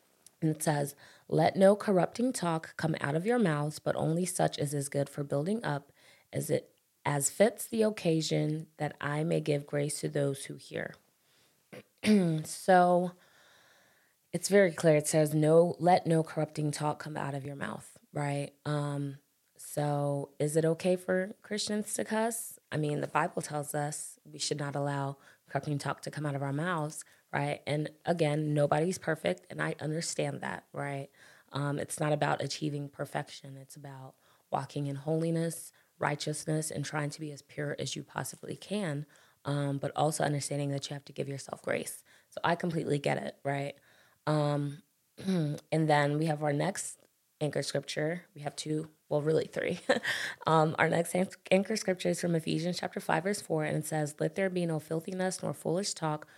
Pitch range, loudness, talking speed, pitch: 145-170 Hz, -32 LUFS, 180 wpm, 150 Hz